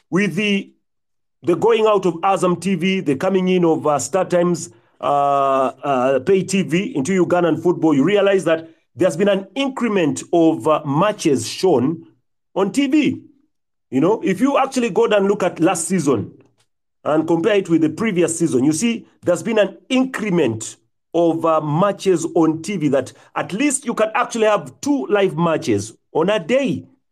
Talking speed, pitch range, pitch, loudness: 175 wpm, 160-210 Hz, 185 Hz, -18 LUFS